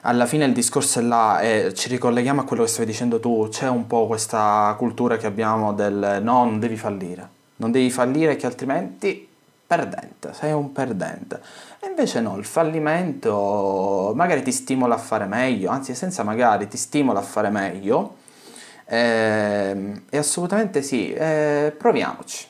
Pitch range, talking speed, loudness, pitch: 110-145 Hz, 160 wpm, -21 LUFS, 120 Hz